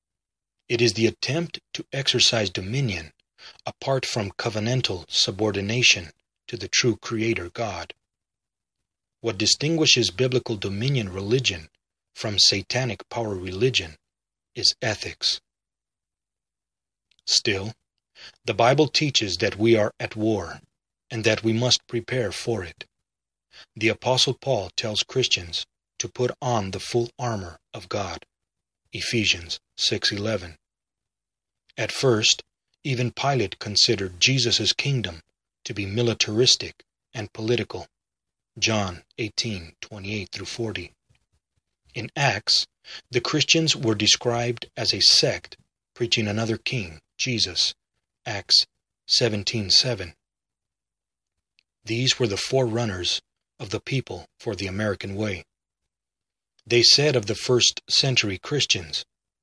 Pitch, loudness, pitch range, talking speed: 115 Hz, -22 LUFS, 100-125 Hz, 110 wpm